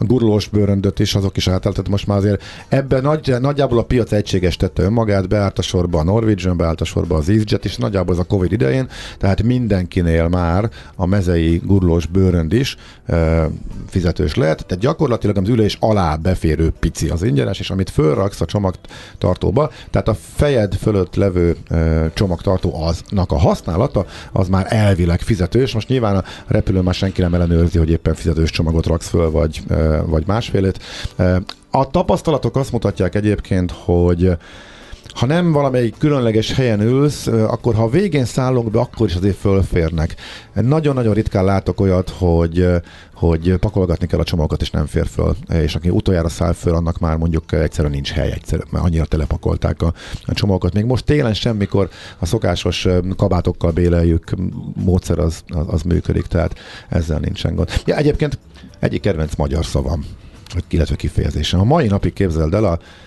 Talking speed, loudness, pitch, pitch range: 165 wpm, -17 LUFS, 95 Hz, 85-110 Hz